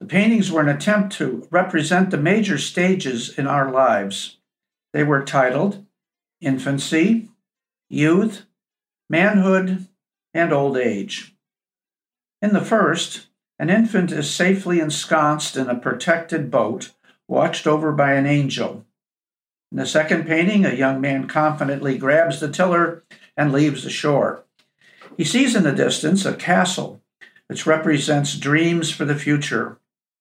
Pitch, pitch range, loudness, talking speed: 160 Hz, 145-190 Hz, -19 LUFS, 135 wpm